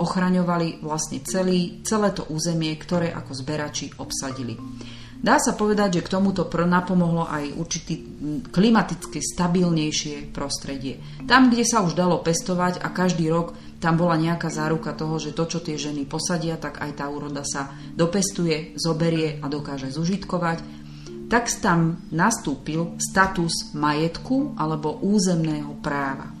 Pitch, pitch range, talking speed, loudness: 165 Hz, 145-180 Hz, 140 wpm, -23 LUFS